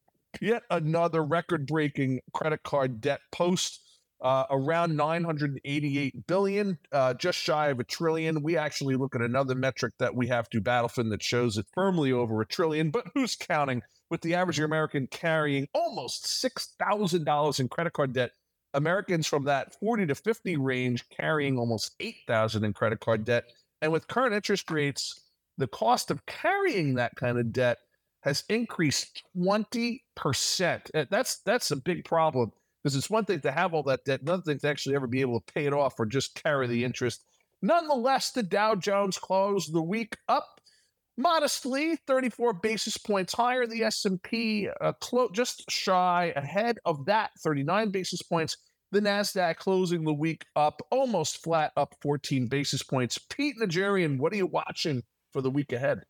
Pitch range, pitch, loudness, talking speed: 135-200 Hz, 160 Hz, -28 LUFS, 170 wpm